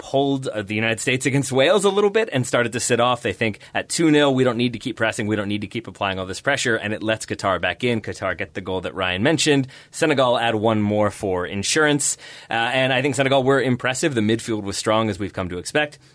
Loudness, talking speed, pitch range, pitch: -21 LUFS, 255 wpm, 105-135 Hz, 115 Hz